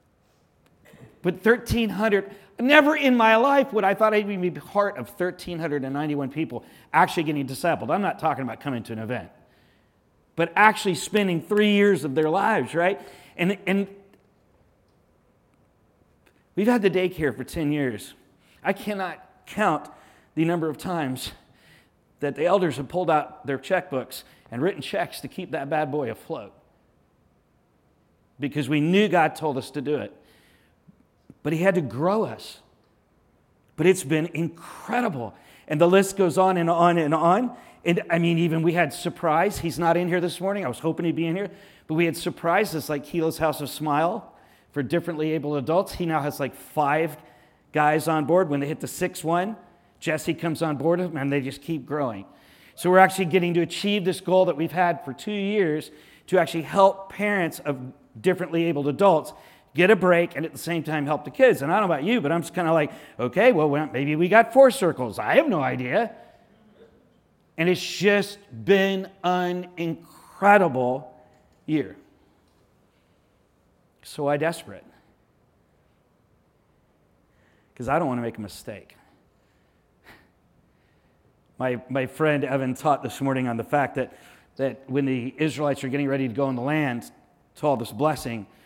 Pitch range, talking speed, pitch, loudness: 145-185 Hz, 170 wpm, 165 Hz, -23 LUFS